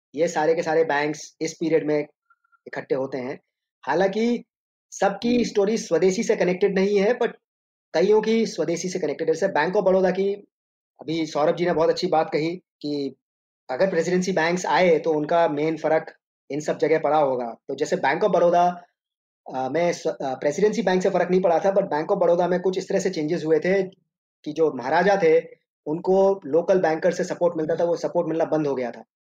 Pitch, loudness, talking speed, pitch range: 175 Hz, -22 LUFS, 195 wpm, 155-195 Hz